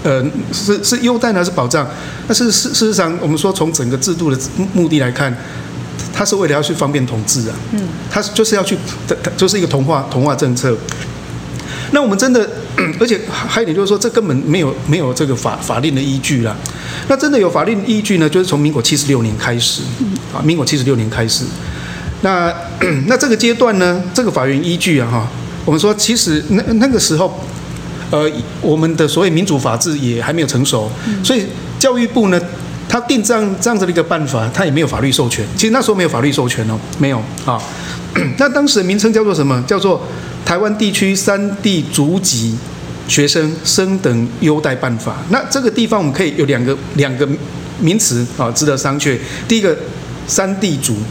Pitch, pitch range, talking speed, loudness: 155 Hz, 135-205 Hz, 300 characters per minute, -14 LUFS